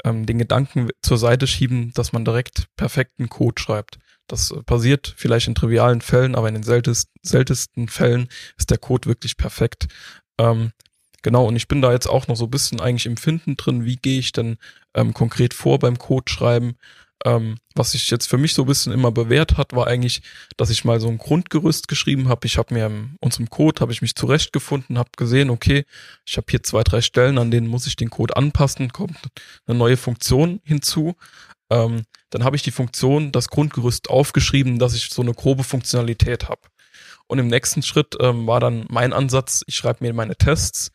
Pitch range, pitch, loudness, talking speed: 115-135 Hz, 120 Hz, -19 LUFS, 195 wpm